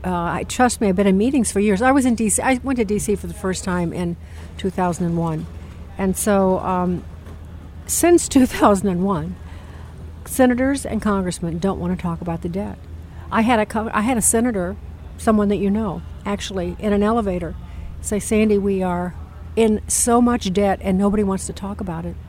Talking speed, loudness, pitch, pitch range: 185 wpm, -19 LUFS, 195 Hz, 170-215 Hz